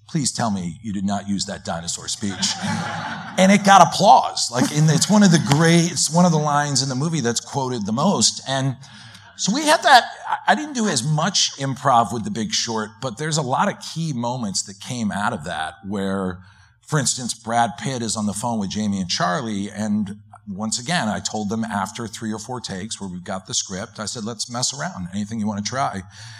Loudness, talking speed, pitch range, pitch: -20 LUFS, 225 wpm, 105-150 Hz, 115 Hz